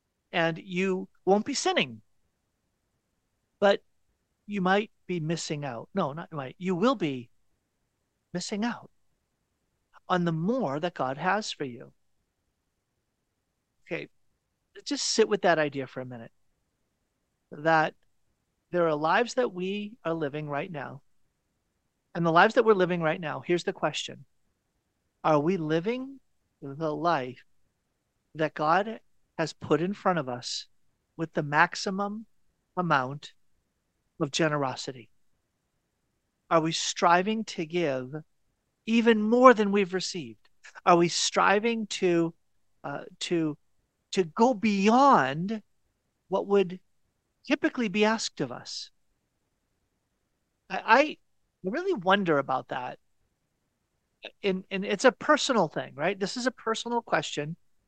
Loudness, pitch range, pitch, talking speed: -27 LUFS, 150-205 Hz, 175 Hz, 125 wpm